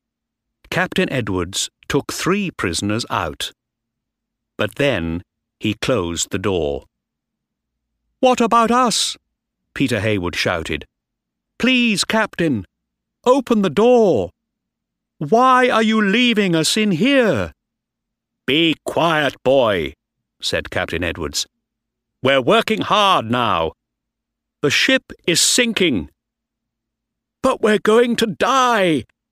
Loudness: -17 LUFS